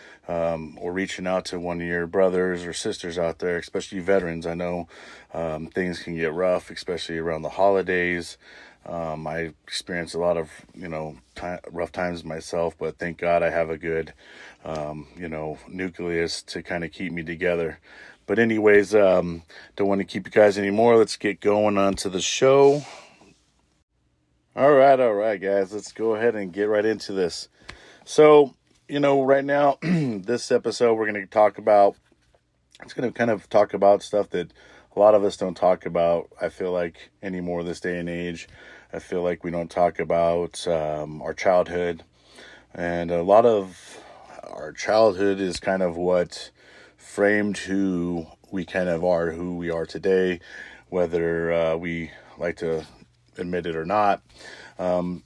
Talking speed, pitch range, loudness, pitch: 175 wpm, 85-100 Hz, -23 LUFS, 90 Hz